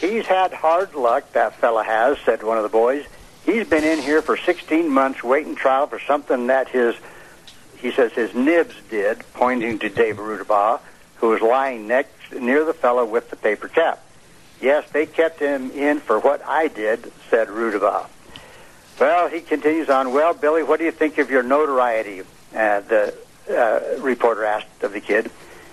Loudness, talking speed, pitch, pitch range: -20 LUFS, 180 wpm, 155 Hz, 135-210 Hz